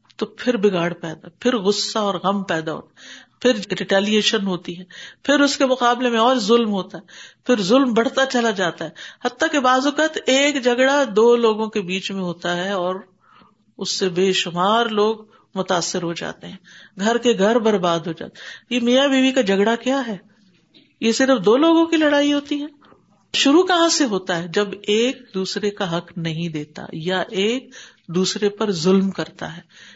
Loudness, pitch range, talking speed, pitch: -19 LUFS, 185-250 Hz, 185 wpm, 210 Hz